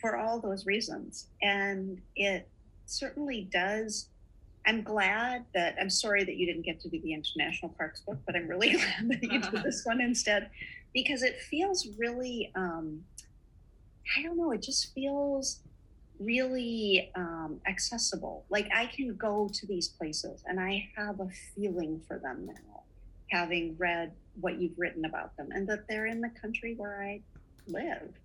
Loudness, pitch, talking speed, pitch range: -32 LUFS, 205 Hz, 165 wpm, 180-235 Hz